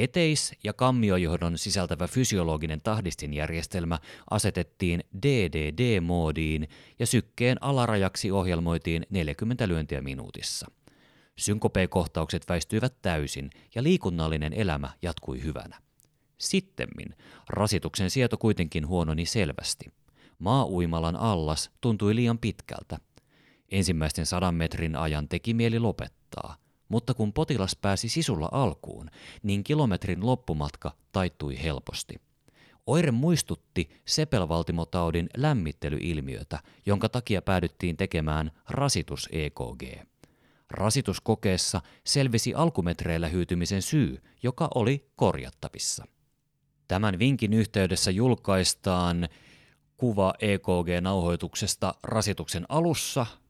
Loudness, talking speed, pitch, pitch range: -28 LUFS, 85 wpm, 95 Hz, 85-120 Hz